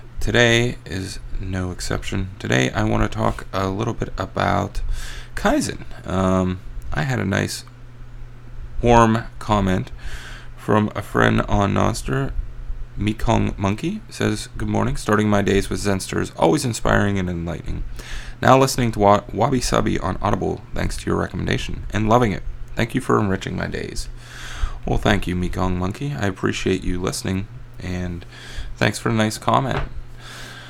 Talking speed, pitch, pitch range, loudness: 145 wpm, 105 Hz, 95-120 Hz, -21 LUFS